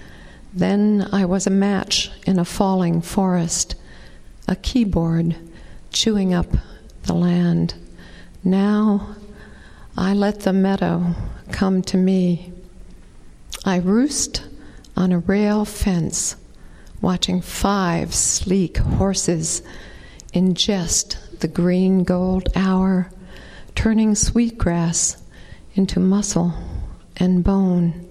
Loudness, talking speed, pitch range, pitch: -19 LUFS, 95 wpm, 170-195 Hz, 185 Hz